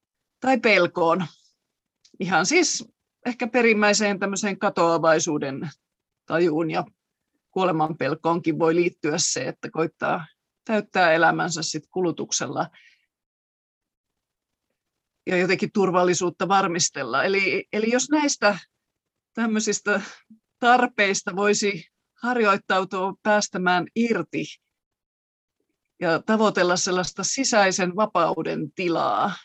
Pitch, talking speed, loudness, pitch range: 190 Hz, 80 wpm, -22 LUFS, 165-210 Hz